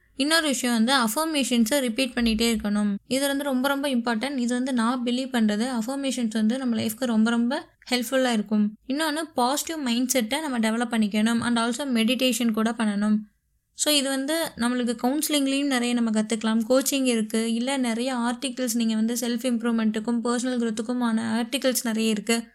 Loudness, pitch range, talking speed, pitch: -24 LUFS, 230-265 Hz, 155 wpm, 240 Hz